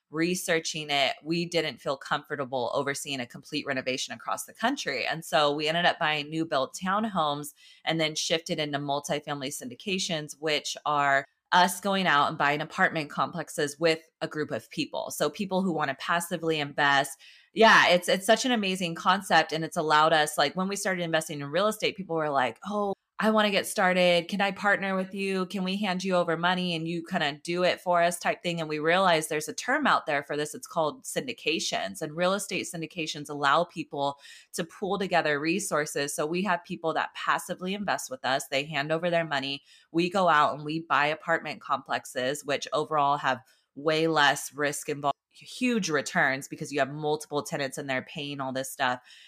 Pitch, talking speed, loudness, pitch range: 160 Hz, 200 wpm, -27 LUFS, 145-180 Hz